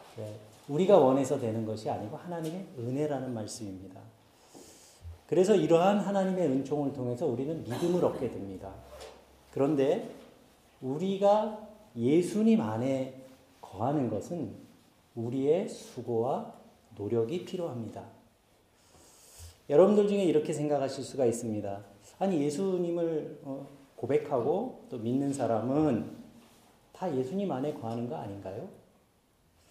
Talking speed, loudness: 265 characters per minute, -30 LUFS